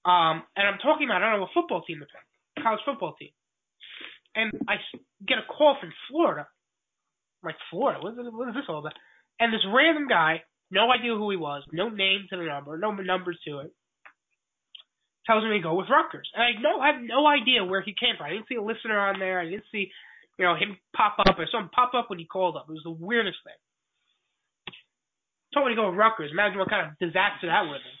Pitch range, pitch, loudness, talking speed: 180-245 Hz, 205 Hz, -25 LUFS, 240 wpm